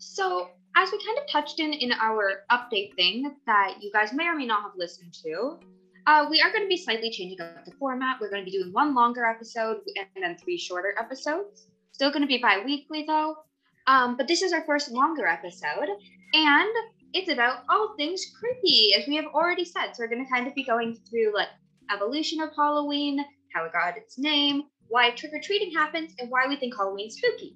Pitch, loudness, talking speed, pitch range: 260 Hz, -25 LUFS, 210 wpm, 205-310 Hz